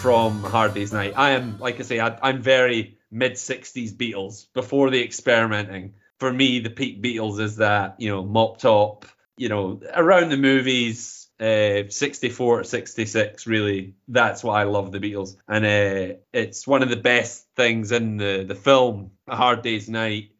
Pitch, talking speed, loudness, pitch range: 115 Hz, 175 wpm, -21 LUFS, 105-125 Hz